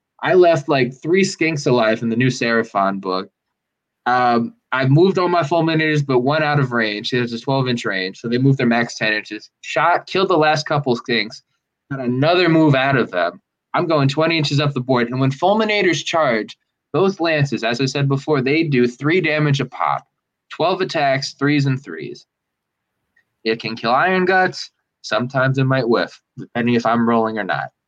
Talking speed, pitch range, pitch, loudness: 195 wpm, 120-155 Hz, 135 Hz, -18 LUFS